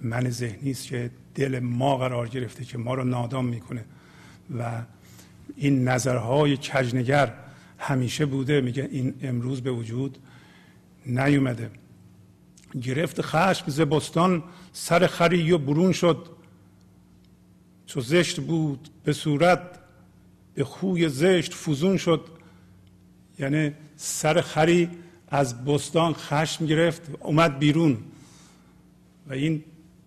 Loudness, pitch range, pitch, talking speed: -25 LUFS, 125-160 Hz, 140 Hz, 110 wpm